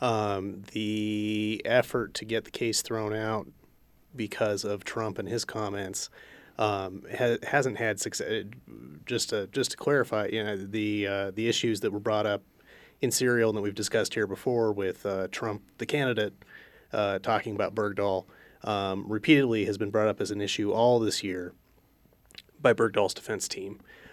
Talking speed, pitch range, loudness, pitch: 170 wpm, 100-110 Hz, -29 LUFS, 105 Hz